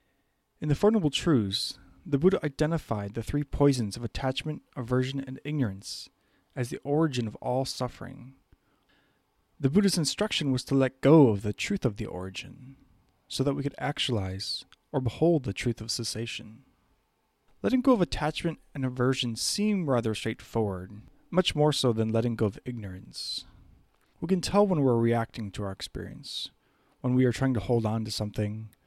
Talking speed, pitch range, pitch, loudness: 170 wpm, 110-145 Hz, 125 Hz, -28 LUFS